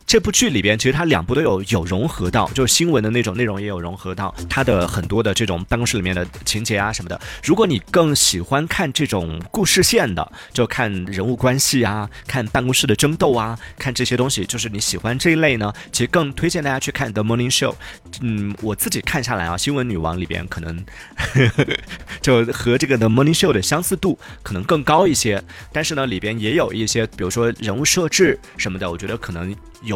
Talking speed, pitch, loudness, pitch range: 365 characters per minute, 115 Hz, -19 LUFS, 95-130 Hz